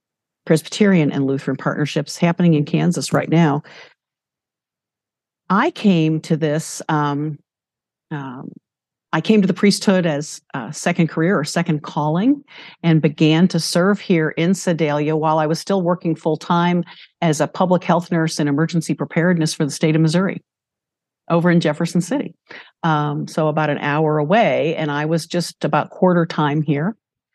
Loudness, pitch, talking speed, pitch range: -18 LUFS, 160 Hz, 160 wpm, 150-175 Hz